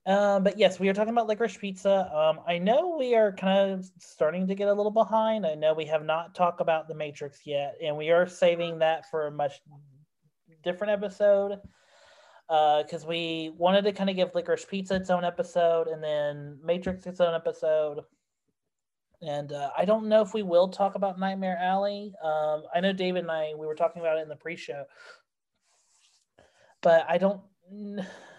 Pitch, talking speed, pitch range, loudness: 175 Hz, 190 wpm, 160-200 Hz, -27 LUFS